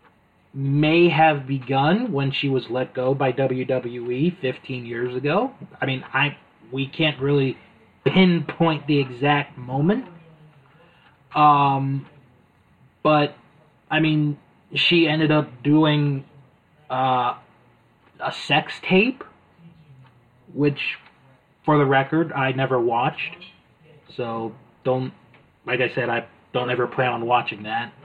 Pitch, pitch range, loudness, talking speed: 140 Hz, 130-155 Hz, -22 LUFS, 115 wpm